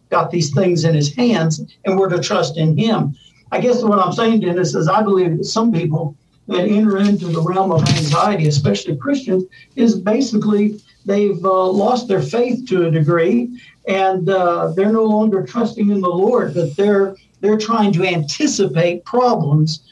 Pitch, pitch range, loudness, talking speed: 190 Hz, 165-210 Hz, -16 LUFS, 180 wpm